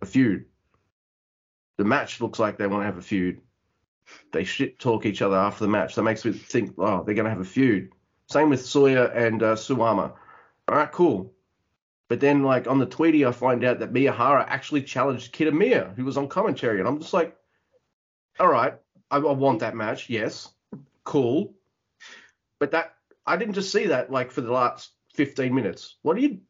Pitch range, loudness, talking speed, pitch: 110-145 Hz, -24 LUFS, 195 wpm, 125 Hz